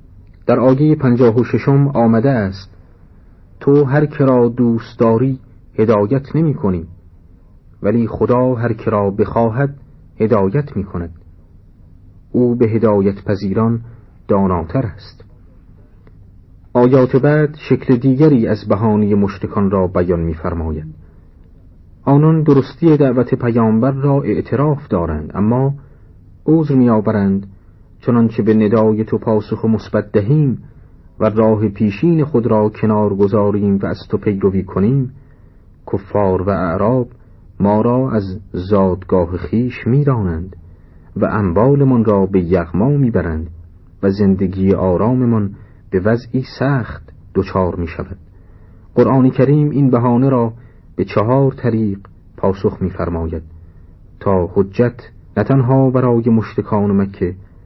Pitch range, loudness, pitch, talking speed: 95-125 Hz, -15 LUFS, 105 Hz, 120 wpm